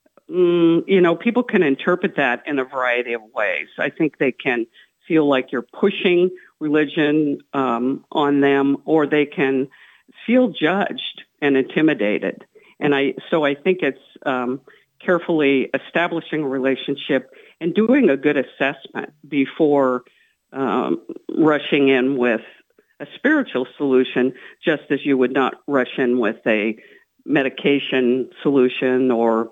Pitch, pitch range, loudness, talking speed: 145 Hz, 130-175 Hz, -19 LUFS, 140 wpm